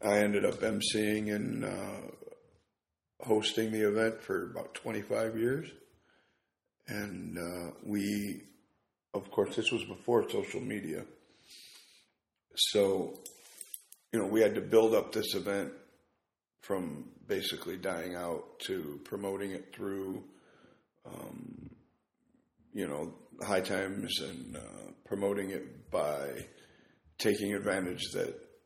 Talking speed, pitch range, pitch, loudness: 115 wpm, 100-110 Hz, 105 Hz, -34 LUFS